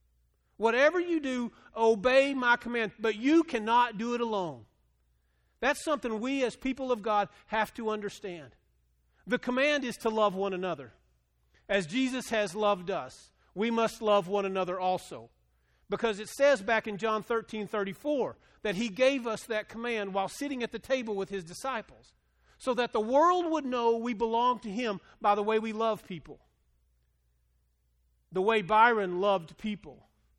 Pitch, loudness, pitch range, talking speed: 215 Hz, -30 LUFS, 180-240 Hz, 160 wpm